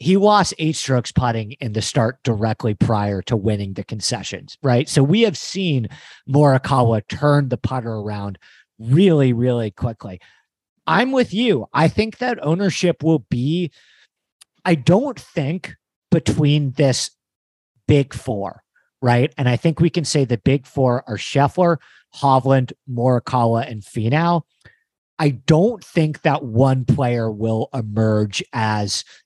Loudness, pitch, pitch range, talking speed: -19 LUFS, 130 Hz, 115-160 Hz, 140 wpm